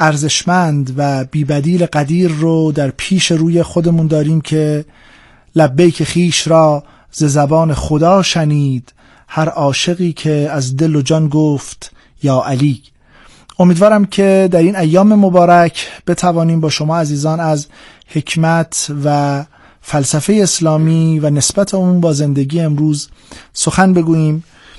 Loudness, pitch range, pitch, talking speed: -13 LUFS, 150-175 Hz, 160 Hz, 125 wpm